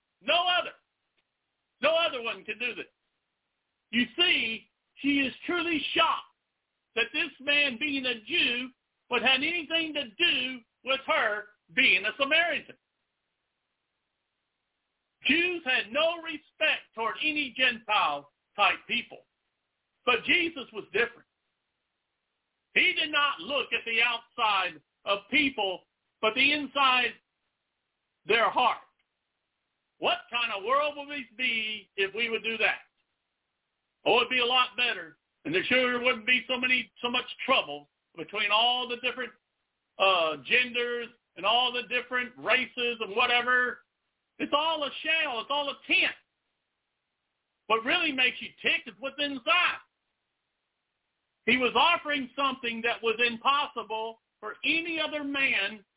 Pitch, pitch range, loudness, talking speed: 255 Hz, 230-295 Hz, -26 LUFS, 135 wpm